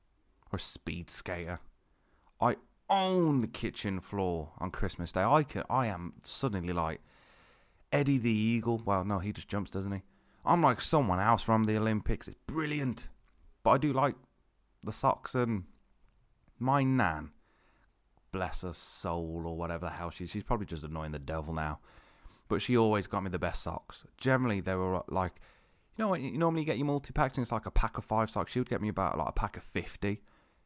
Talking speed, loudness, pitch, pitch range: 195 wpm, -33 LUFS, 100 Hz, 85-120 Hz